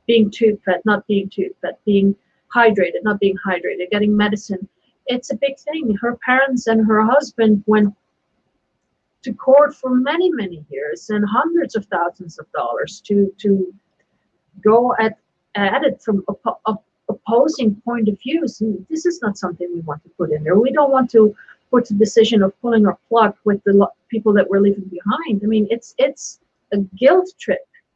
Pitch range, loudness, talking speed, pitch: 200-245 Hz, -18 LUFS, 185 wpm, 215 Hz